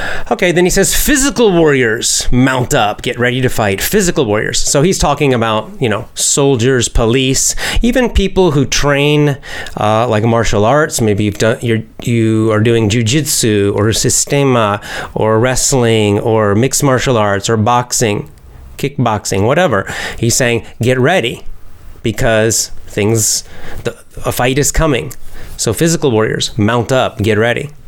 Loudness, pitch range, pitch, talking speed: -12 LUFS, 105-140 Hz, 120 Hz, 145 wpm